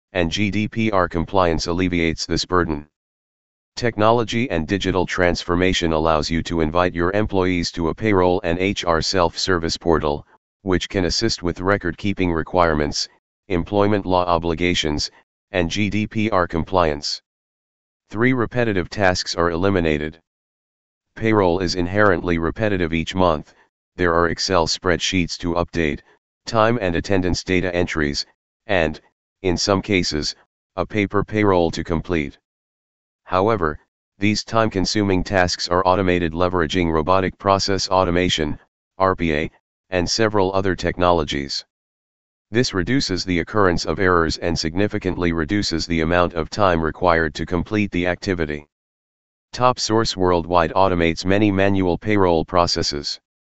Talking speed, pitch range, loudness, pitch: 120 wpm, 85-100 Hz, -20 LUFS, 90 Hz